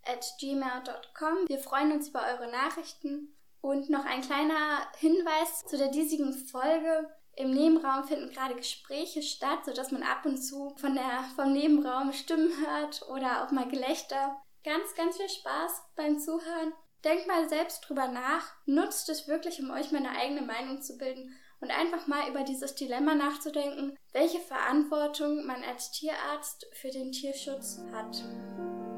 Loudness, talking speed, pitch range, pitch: -32 LUFS, 155 wpm, 265-315 Hz, 285 Hz